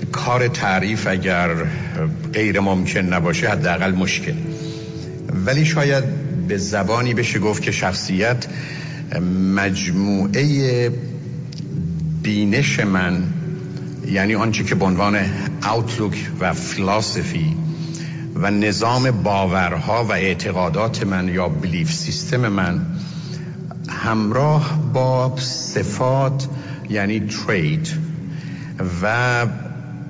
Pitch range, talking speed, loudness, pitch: 100-160 Hz, 85 wpm, -20 LUFS, 130 Hz